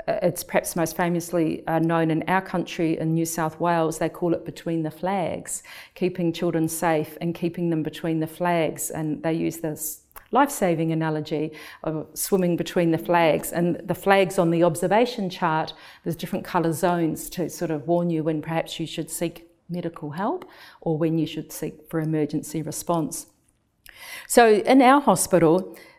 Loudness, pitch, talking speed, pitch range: -24 LUFS, 165 Hz, 170 wpm, 160-180 Hz